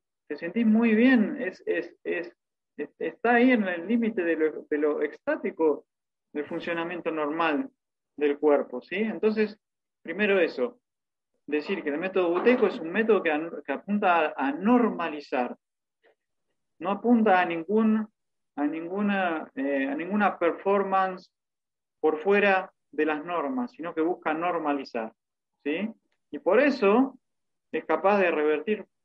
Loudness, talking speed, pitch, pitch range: -26 LUFS, 140 wpm, 185 Hz, 155-220 Hz